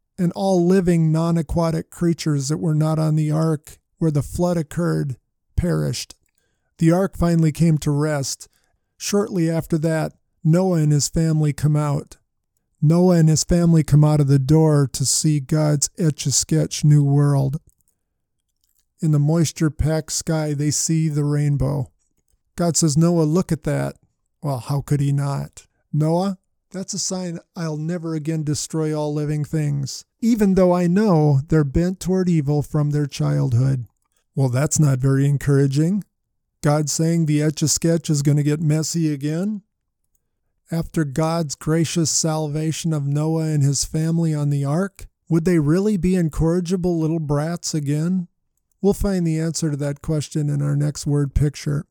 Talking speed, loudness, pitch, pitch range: 160 wpm, -20 LUFS, 155 Hz, 145-165 Hz